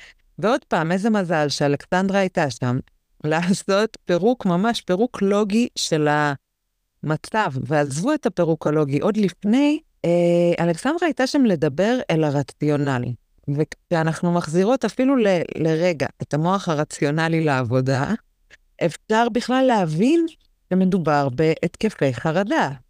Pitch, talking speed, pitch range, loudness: 175 Hz, 105 wpm, 150-220 Hz, -21 LUFS